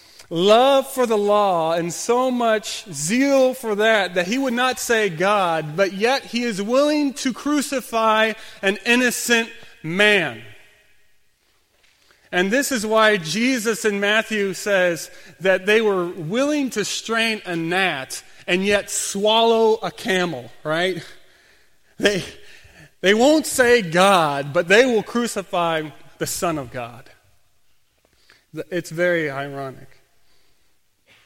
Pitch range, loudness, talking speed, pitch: 170-230 Hz, -19 LUFS, 125 wpm, 205 Hz